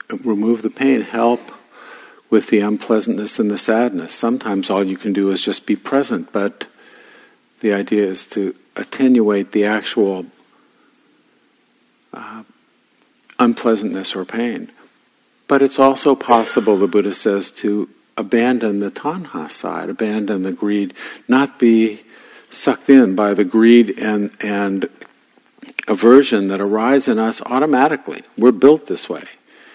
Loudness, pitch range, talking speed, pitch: -16 LUFS, 100-120 Hz, 130 wpm, 110 Hz